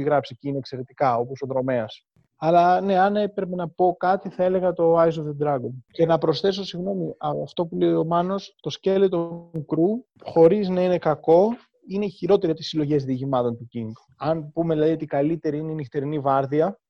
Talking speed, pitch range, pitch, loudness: 200 wpm, 145-180 Hz, 165 Hz, -23 LUFS